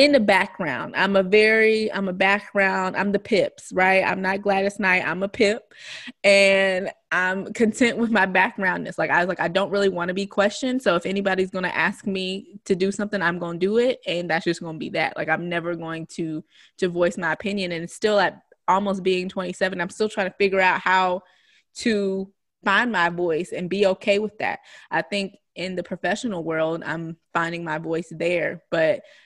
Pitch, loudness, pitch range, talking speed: 190 Hz, -22 LUFS, 175-200 Hz, 205 wpm